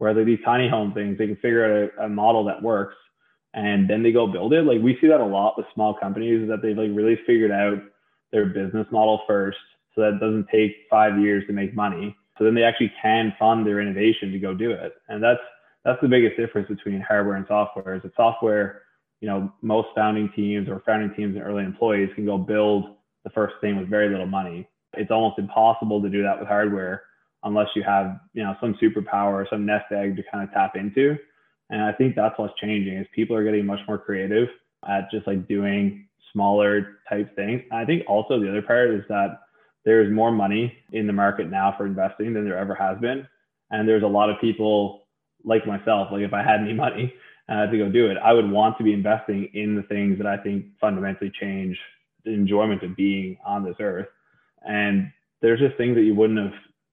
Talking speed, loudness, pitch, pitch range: 225 wpm, -22 LUFS, 105 Hz, 100-110 Hz